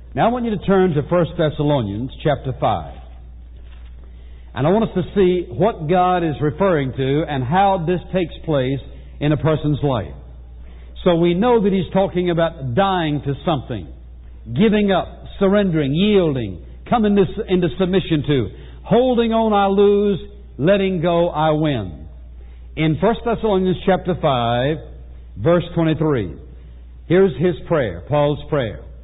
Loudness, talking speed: -18 LUFS, 145 wpm